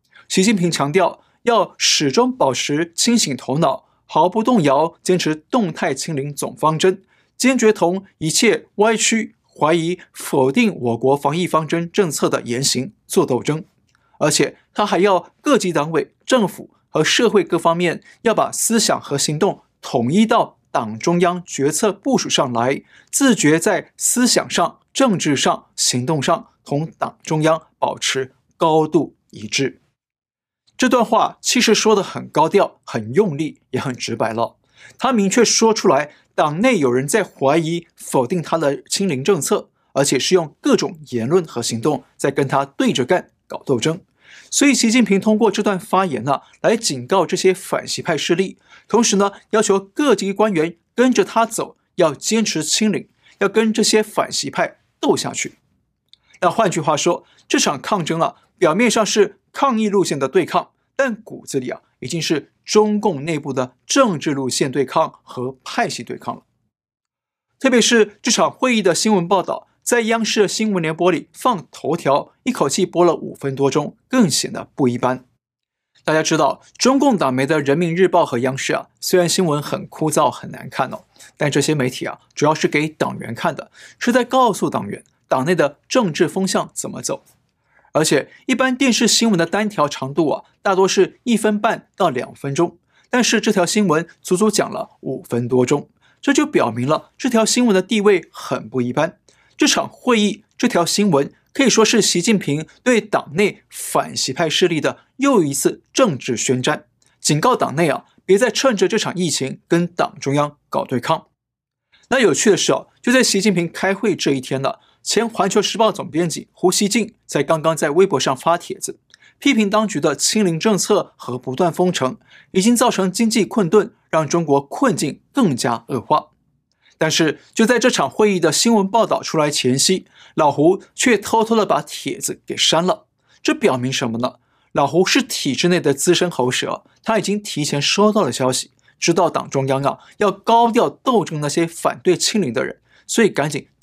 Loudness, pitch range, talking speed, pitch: -18 LUFS, 150-220 Hz, 255 characters per minute, 180 Hz